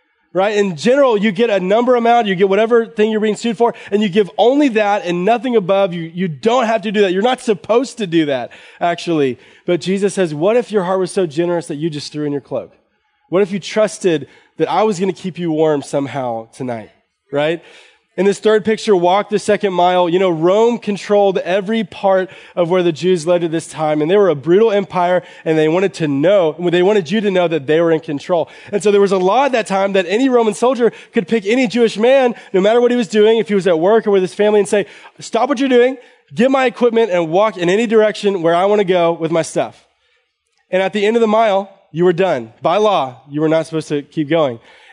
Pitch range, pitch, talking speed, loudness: 170-220 Hz, 195 Hz, 250 wpm, -15 LUFS